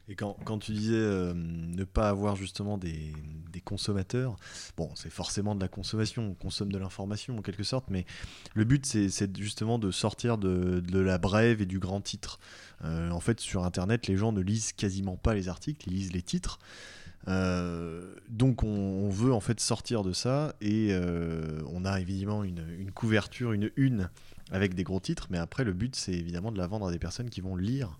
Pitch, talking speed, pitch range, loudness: 100 Hz, 210 wpm, 90-110 Hz, -31 LUFS